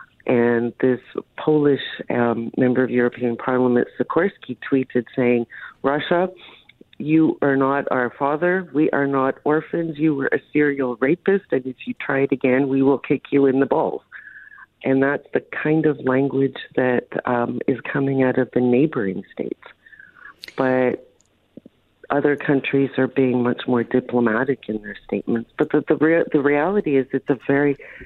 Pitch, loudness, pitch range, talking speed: 135 Hz, -20 LUFS, 125-145 Hz, 160 wpm